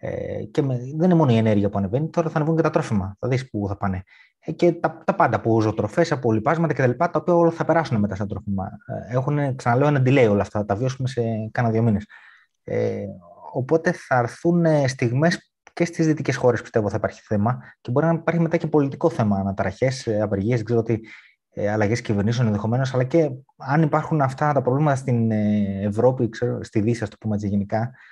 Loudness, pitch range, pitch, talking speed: -22 LUFS, 105-155 Hz, 125 Hz, 205 wpm